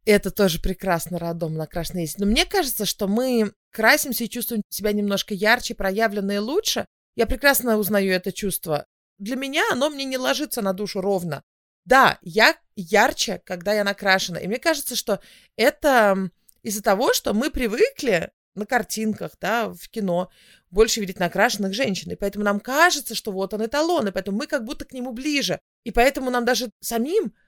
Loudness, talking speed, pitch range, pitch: -22 LUFS, 170 wpm, 195-255 Hz, 215 Hz